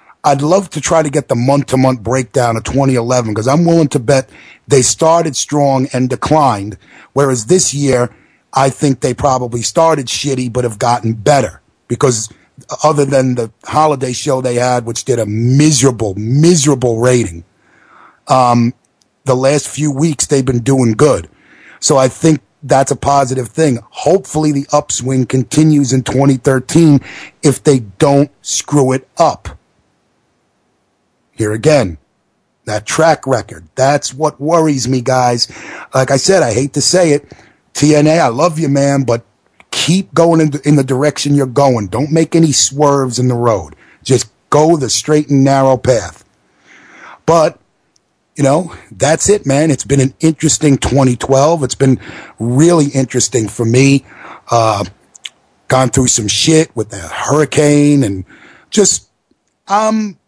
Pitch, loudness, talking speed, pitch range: 135 Hz, -12 LUFS, 150 wpm, 120-150 Hz